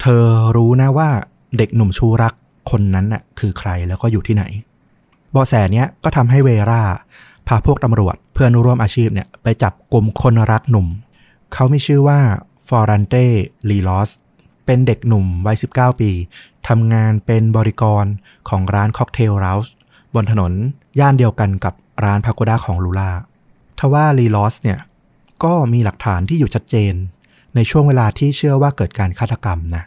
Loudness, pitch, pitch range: -15 LUFS, 115 Hz, 100-125 Hz